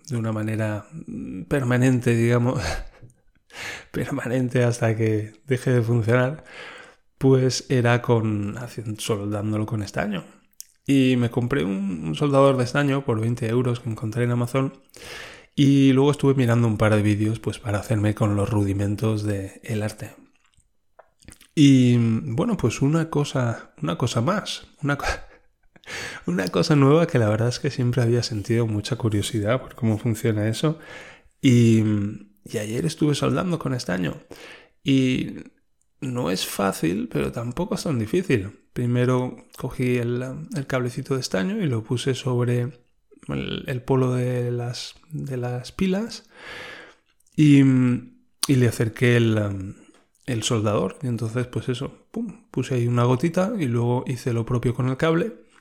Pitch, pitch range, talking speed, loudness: 125 Hz, 115-135 Hz, 145 wpm, -23 LUFS